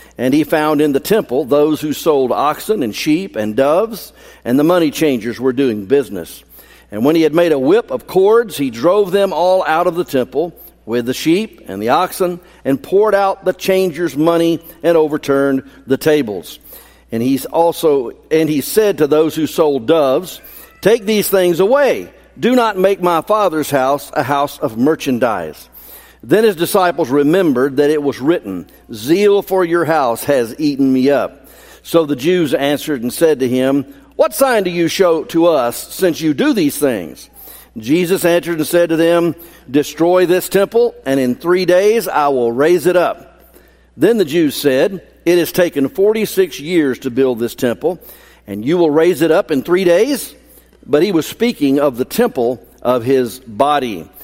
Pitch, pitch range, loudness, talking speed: 165 Hz, 140-185 Hz, -14 LUFS, 185 wpm